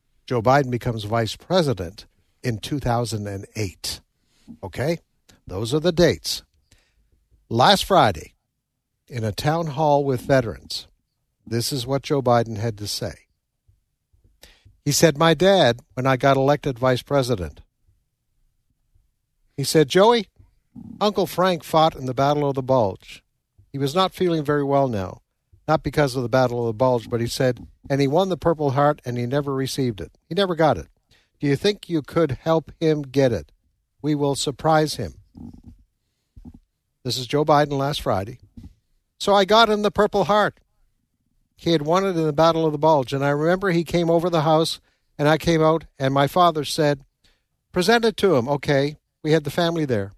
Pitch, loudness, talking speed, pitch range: 140 Hz, -21 LUFS, 175 wpm, 115-160 Hz